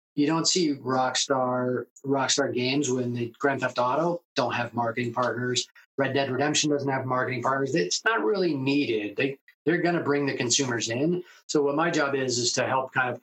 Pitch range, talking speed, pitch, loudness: 125-145 Hz, 195 wpm, 135 Hz, -26 LUFS